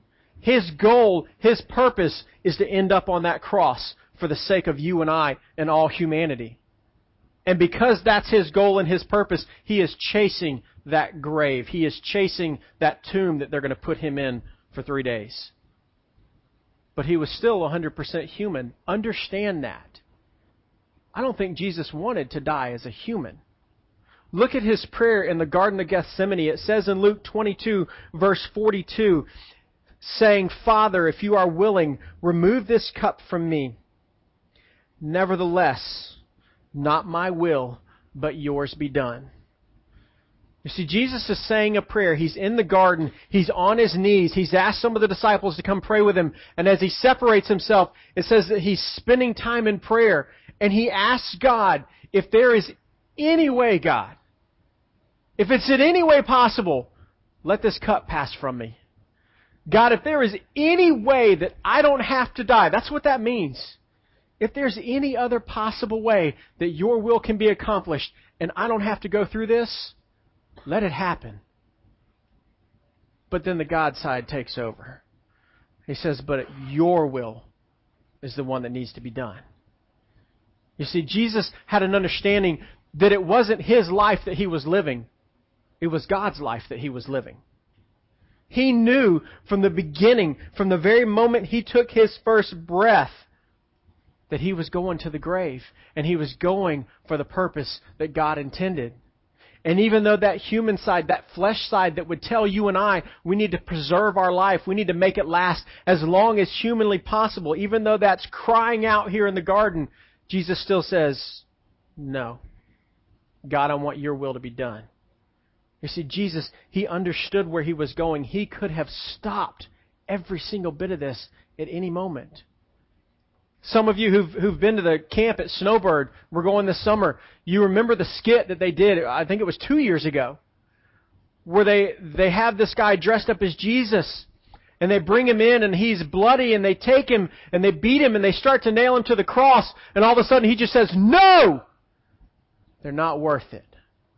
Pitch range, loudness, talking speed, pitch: 140-215 Hz, -21 LUFS, 180 wpm, 185 Hz